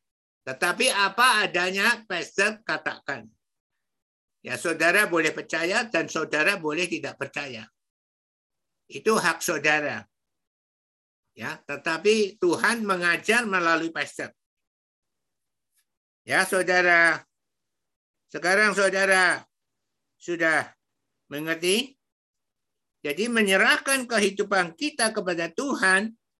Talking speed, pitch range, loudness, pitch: 80 wpm, 150-205 Hz, -23 LUFS, 175 Hz